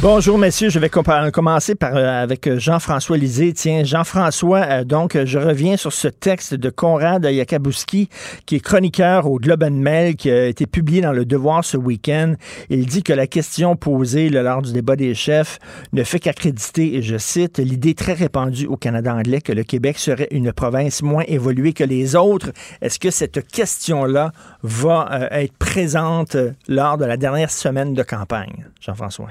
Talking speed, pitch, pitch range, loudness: 180 wpm, 150 Hz, 130-165 Hz, -17 LUFS